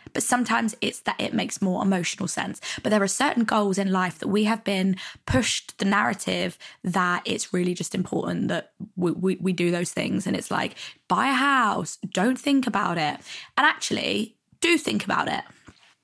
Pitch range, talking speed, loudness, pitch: 185-230 Hz, 190 wpm, -24 LUFS, 195 Hz